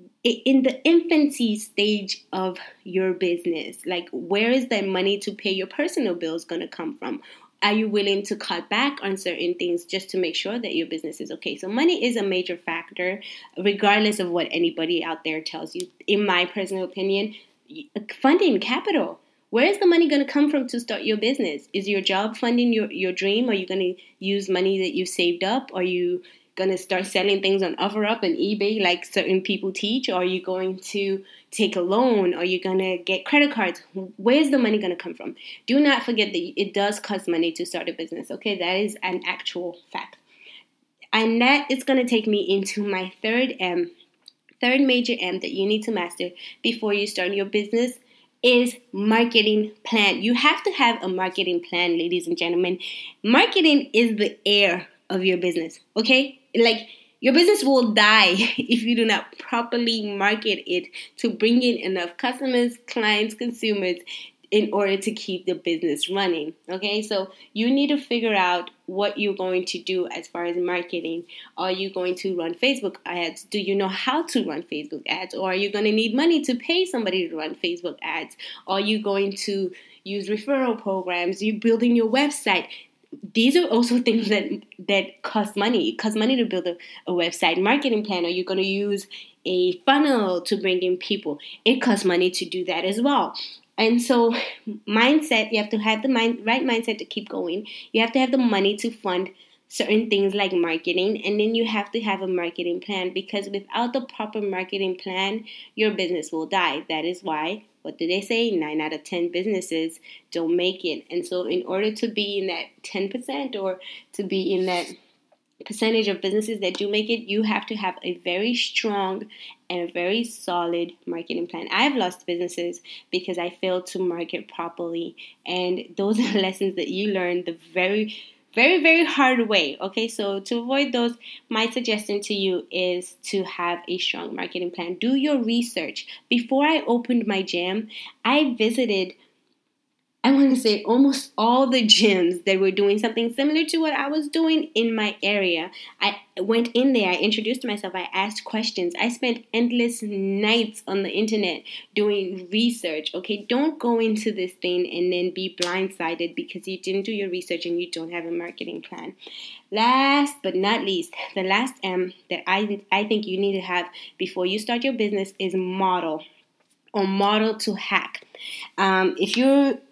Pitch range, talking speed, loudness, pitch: 185-235 Hz, 190 wpm, -23 LUFS, 205 Hz